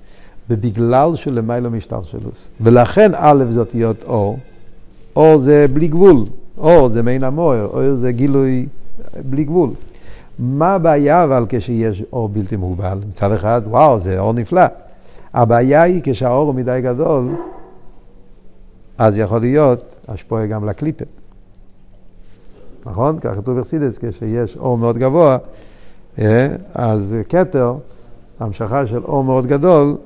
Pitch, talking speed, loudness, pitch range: 120 Hz, 125 wpm, -14 LUFS, 110-135 Hz